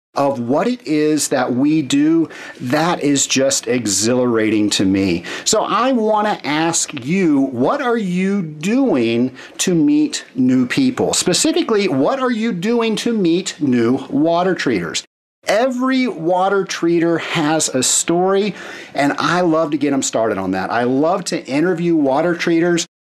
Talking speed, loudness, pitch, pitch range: 150 wpm, -16 LUFS, 175 Hz, 145-235 Hz